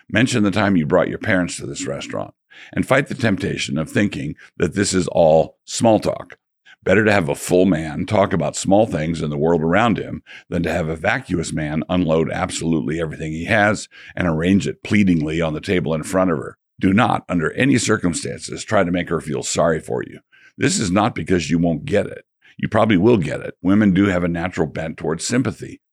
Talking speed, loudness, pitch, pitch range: 215 wpm, -19 LUFS, 90 Hz, 80-100 Hz